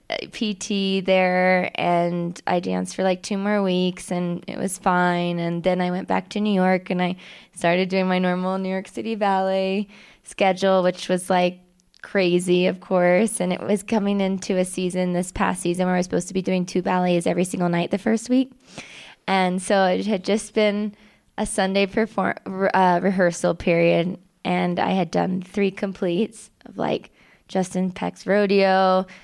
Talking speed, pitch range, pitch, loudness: 180 wpm, 180-200 Hz, 185 Hz, -22 LUFS